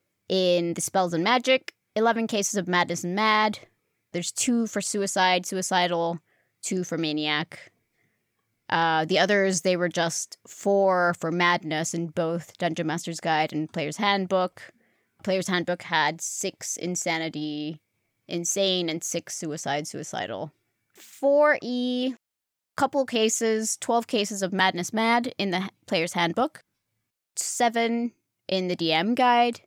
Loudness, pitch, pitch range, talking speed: -25 LUFS, 180 Hz, 165-215 Hz, 125 wpm